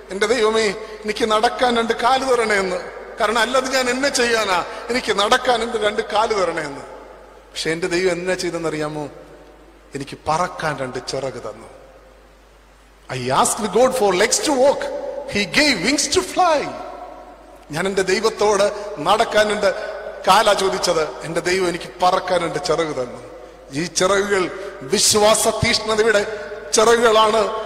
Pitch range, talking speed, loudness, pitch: 180-240 Hz, 130 wpm, -18 LUFS, 210 Hz